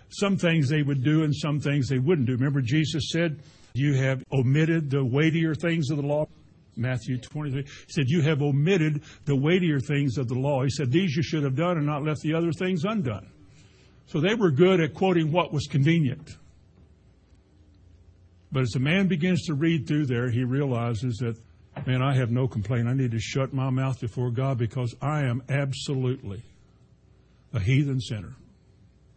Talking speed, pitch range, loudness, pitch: 185 wpm, 125-155 Hz, -25 LUFS, 140 Hz